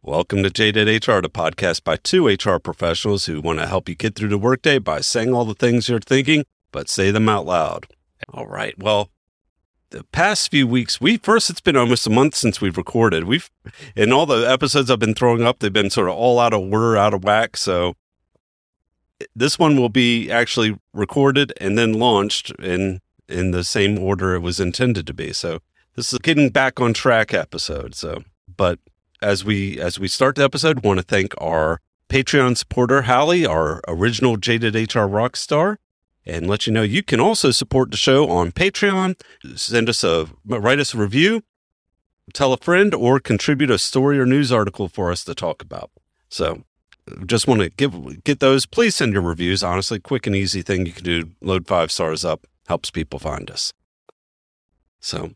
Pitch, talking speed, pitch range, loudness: 110 Hz, 195 wpm, 95-130 Hz, -18 LUFS